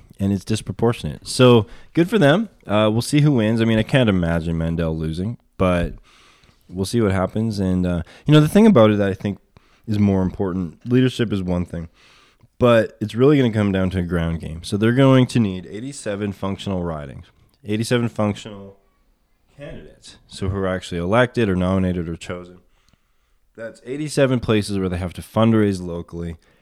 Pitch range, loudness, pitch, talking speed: 90-115 Hz, -19 LUFS, 100 Hz, 185 wpm